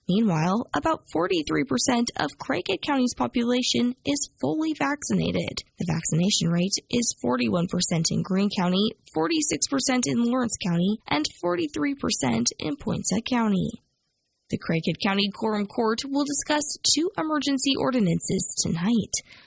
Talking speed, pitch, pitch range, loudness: 115 wpm, 220 Hz, 180-255 Hz, -24 LUFS